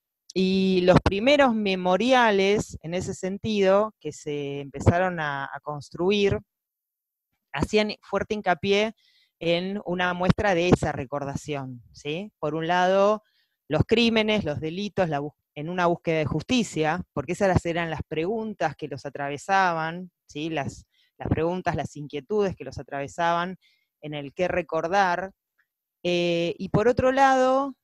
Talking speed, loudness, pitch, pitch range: 135 wpm, -25 LUFS, 180 Hz, 150-200 Hz